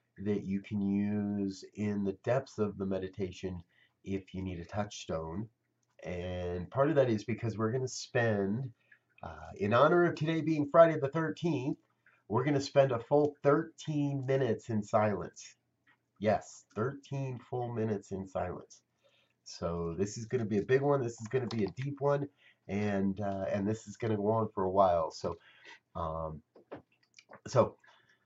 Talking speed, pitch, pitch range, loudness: 175 wpm, 110 Hz, 100-135 Hz, -33 LUFS